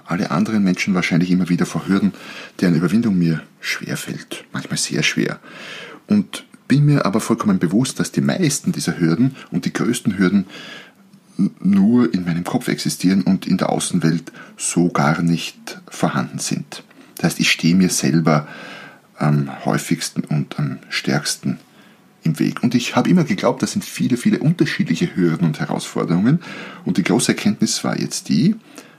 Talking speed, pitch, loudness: 160 wpm, 110 Hz, -19 LUFS